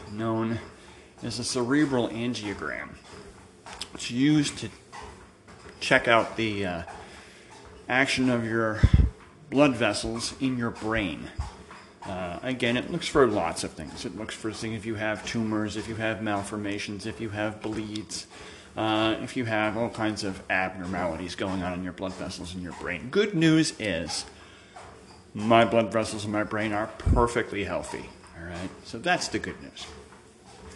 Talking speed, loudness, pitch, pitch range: 155 wpm, -27 LUFS, 110 Hz, 100-120 Hz